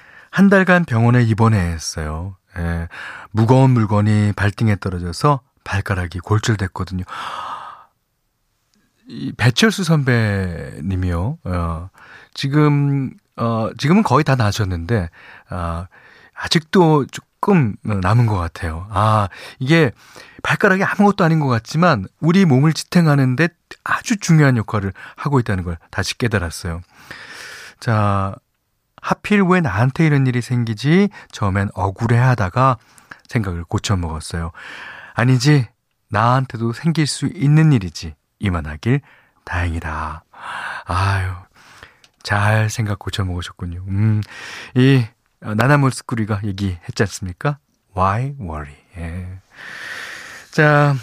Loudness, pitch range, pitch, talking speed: -18 LUFS, 95-140 Hz, 110 Hz, 250 characters per minute